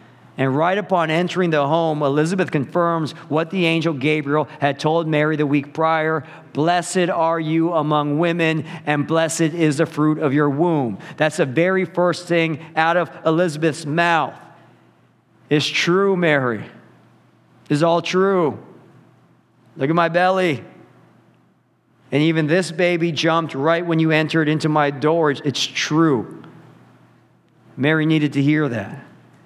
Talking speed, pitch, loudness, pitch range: 140 wpm, 160 Hz, -19 LUFS, 150-170 Hz